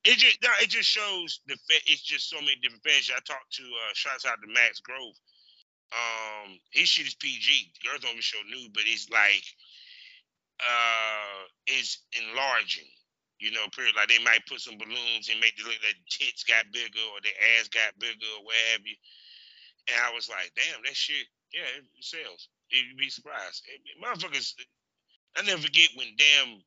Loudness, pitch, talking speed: -25 LUFS, 115 Hz, 185 wpm